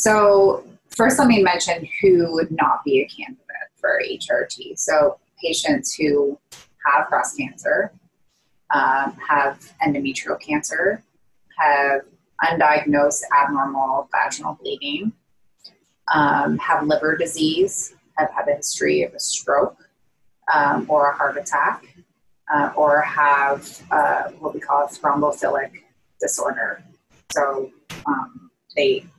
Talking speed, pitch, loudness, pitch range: 115 wpm, 165 Hz, -20 LUFS, 145-235 Hz